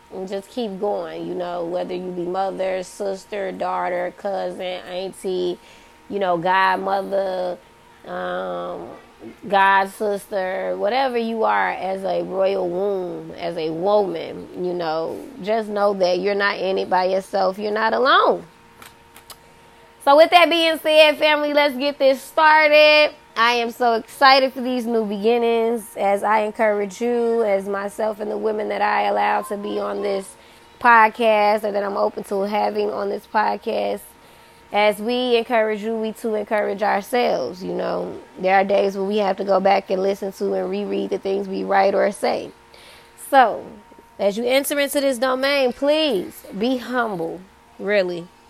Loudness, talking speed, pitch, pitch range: -20 LUFS, 160 wpm, 200 Hz, 185-230 Hz